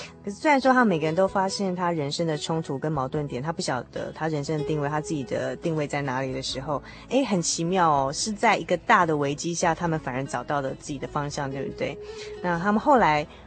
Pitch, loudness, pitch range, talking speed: 155 Hz, -25 LUFS, 145-185 Hz, 350 characters per minute